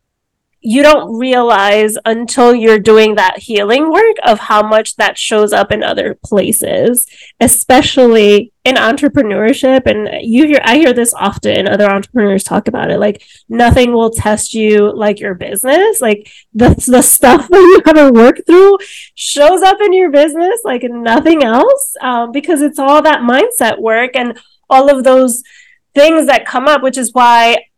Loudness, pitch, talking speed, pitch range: -9 LUFS, 250 Hz, 165 wpm, 220-290 Hz